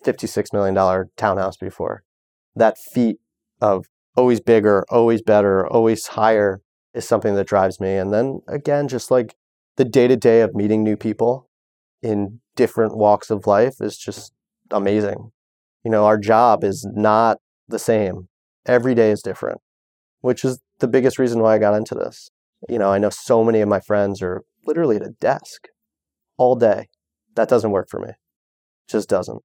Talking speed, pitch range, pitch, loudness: 170 wpm, 95-115 Hz, 105 Hz, -18 LUFS